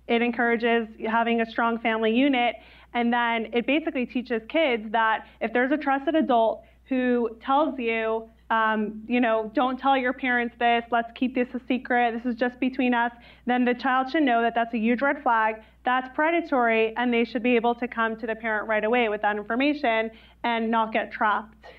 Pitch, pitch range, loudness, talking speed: 235 Hz, 225-255 Hz, -24 LUFS, 200 wpm